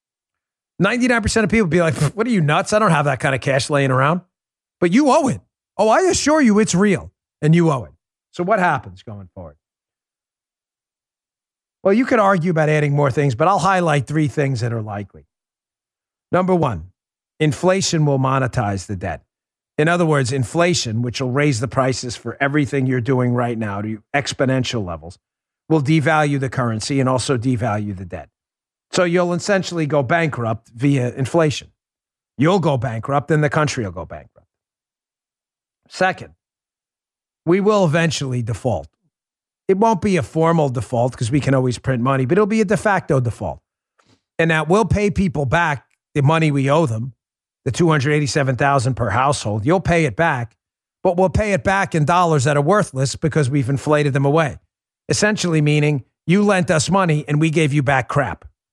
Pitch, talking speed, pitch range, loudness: 145 Hz, 175 wpm, 125-170 Hz, -18 LUFS